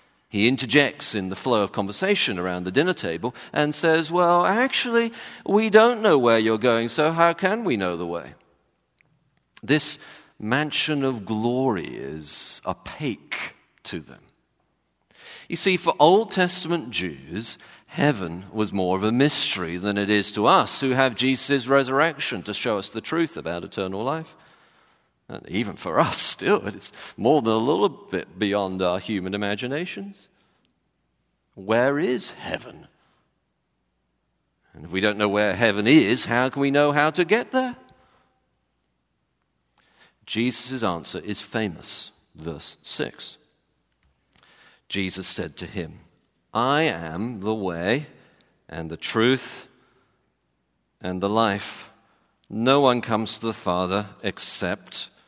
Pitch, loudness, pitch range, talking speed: 115 Hz, -23 LUFS, 95-150 Hz, 135 wpm